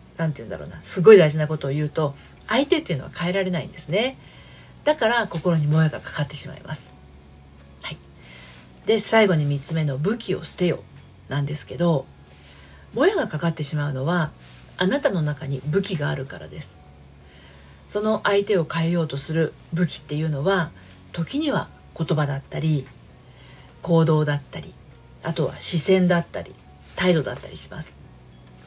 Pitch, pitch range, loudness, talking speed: 155 Hz, 130-175 Hz, -23 LUFS, 330 characters per minute